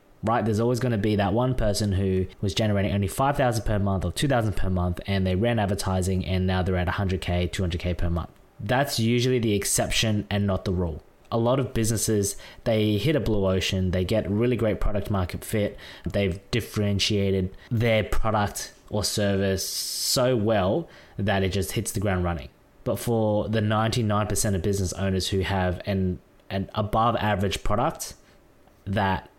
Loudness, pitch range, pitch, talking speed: -25 LUFS, 95-110 Hz, 100 Hz, 175 wpm